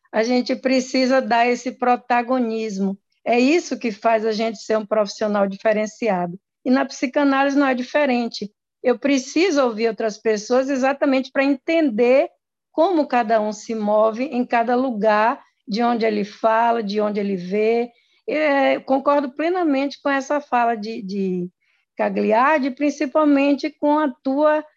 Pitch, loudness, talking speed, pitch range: 245 Hz, -20 LUFS, 145 wpm, 220-280 Hz